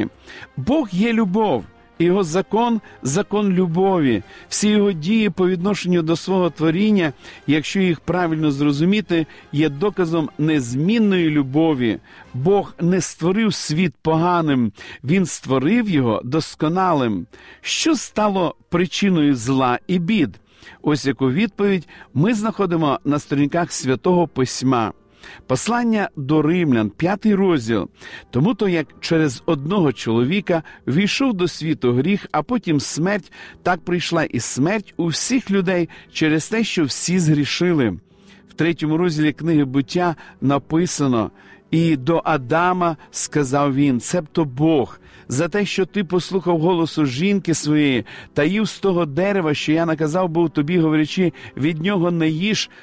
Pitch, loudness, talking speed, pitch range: 170 Hz, -19 LUFS, 130 wpm, 150-190 Hz